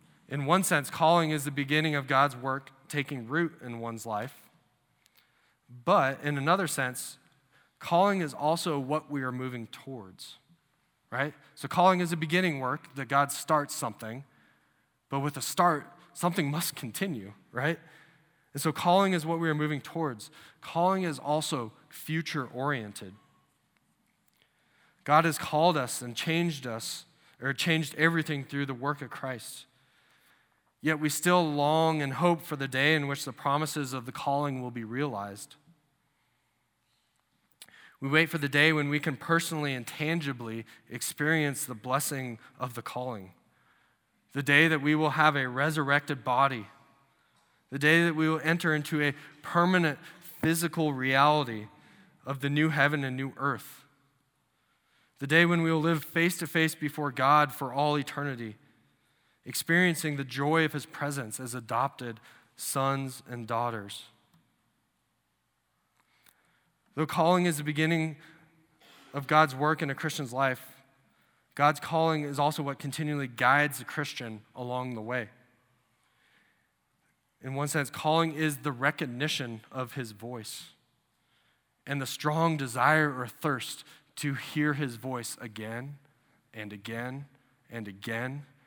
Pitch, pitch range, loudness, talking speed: 145 Hz, 130-155 Hz, -29 LUFS, 145 wpm